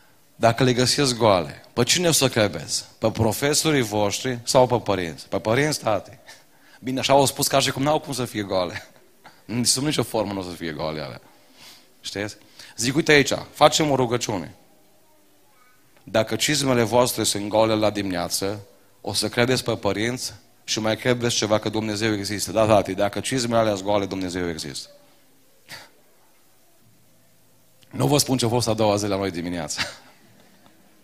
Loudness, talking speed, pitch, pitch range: -22 LUFS, 170 wpm, 110 Hz, 100-130 Hz